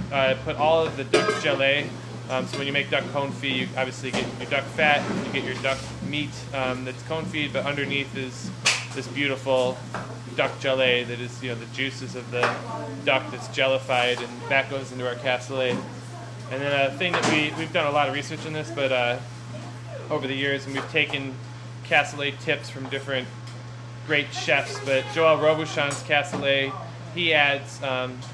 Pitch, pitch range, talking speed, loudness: 135 Hz, 125-140 Hz, 185 wpm, -25 LUFS